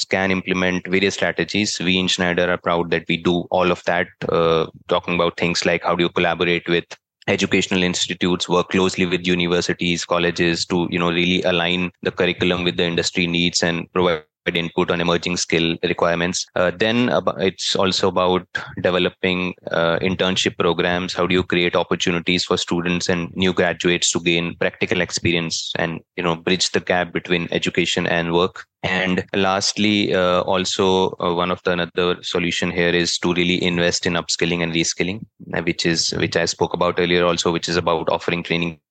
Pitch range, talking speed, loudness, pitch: 85-90 Hz, 180 wpm, -19 LUFS, 90 Hz